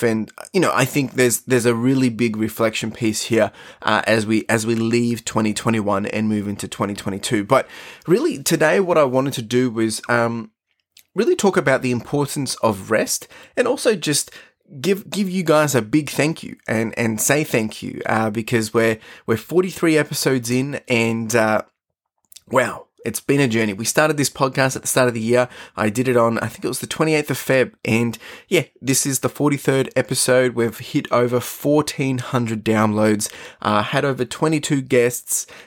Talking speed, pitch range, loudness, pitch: 185 wpm, 110-140 Hz, -19 LUFS, 125 Hz